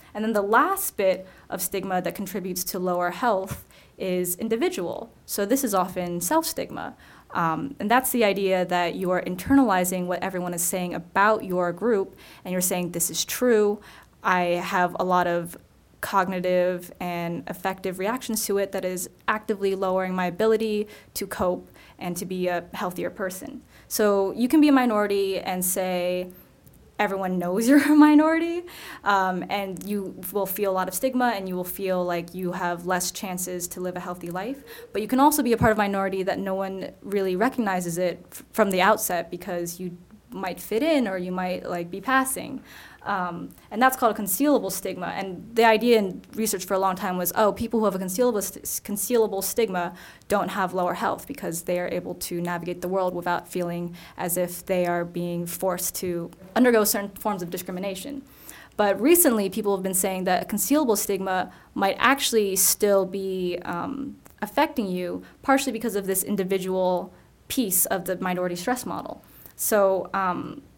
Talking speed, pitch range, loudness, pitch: 185 wpm, 180-220 Hz, -24 LUFS, 190 Hz